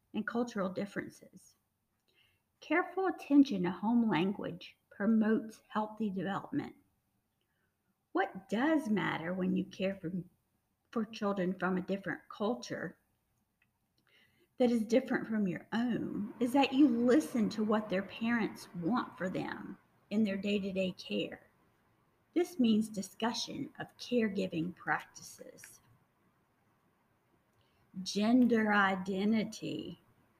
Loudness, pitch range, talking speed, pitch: -34 LUFS, 180-235 Hz, 110 wpm, 205 Hz